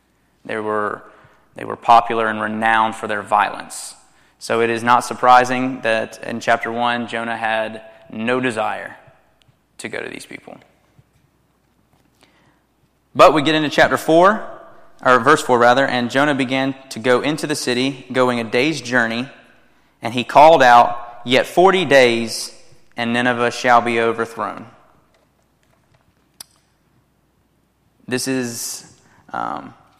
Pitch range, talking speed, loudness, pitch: 115-130 Hz, 130 wpm, -16 LUFS, 120 Hz